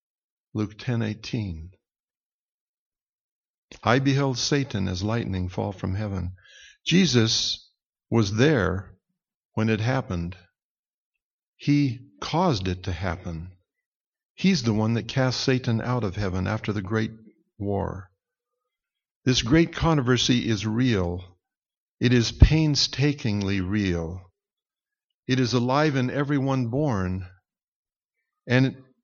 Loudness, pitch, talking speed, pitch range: -24 LUFS, 115 Hz, 105 wpm, 100-140 Hz